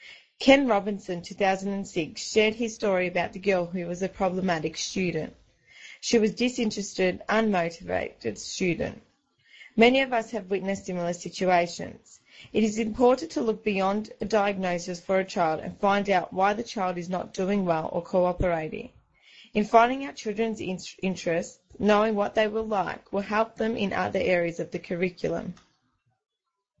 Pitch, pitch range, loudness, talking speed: 195 Hz, 180-220 Hz, -26 LUFS, 155 wpm